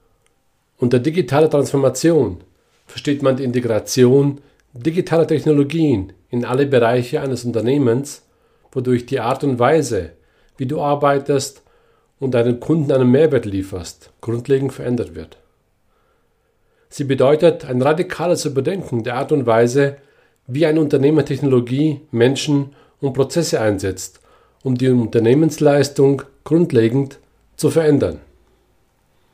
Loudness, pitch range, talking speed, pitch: -17 LUFS, 125-150 Hz, 110 wpm, 135 Hz